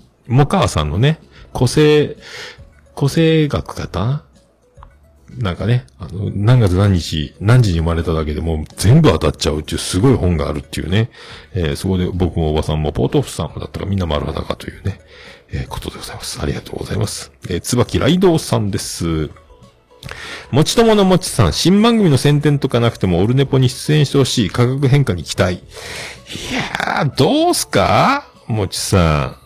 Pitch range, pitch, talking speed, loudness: 85-140 Hz, 105 Hz, 345 characters per minute, -16 LUFS